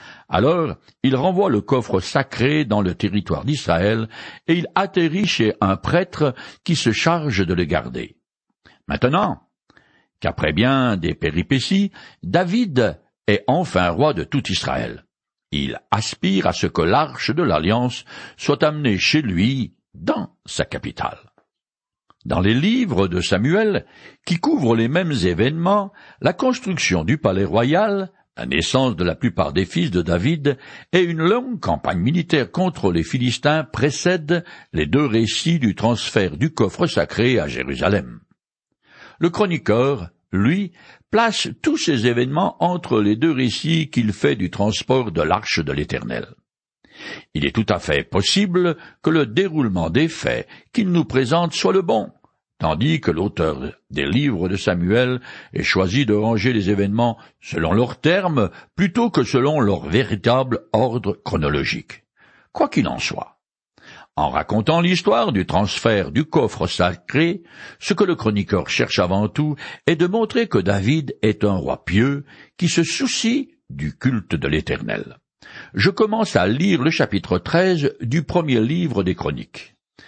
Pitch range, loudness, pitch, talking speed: 105-175 Hz, -20 LUFS, 135 Hz, 150 wpm